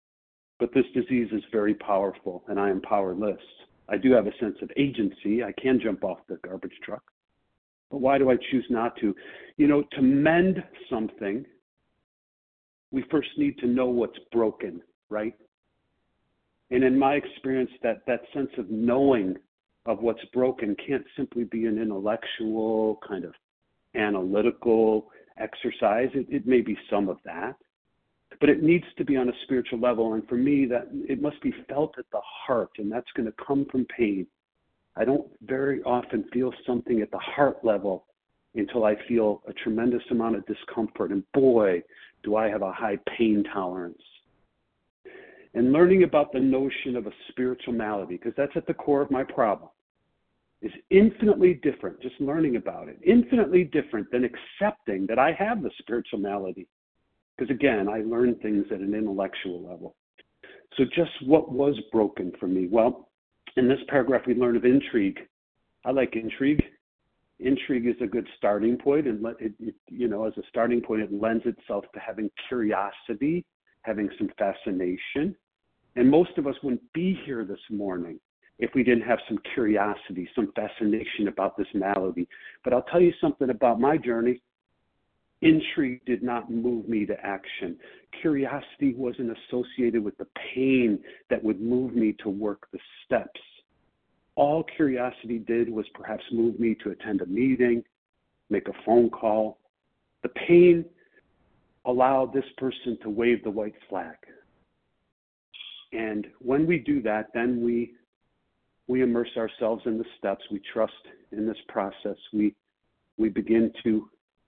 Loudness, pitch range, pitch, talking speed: -26 LUFS, 110-135 Hz, 120 Hz, 160 wpm